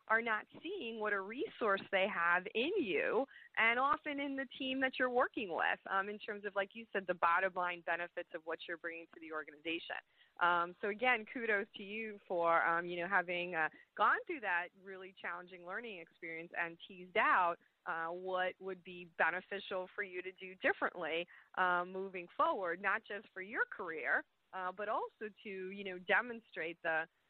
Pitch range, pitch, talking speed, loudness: 175-225 Hz, 190 Hz, 185 wpm, -37 LUFS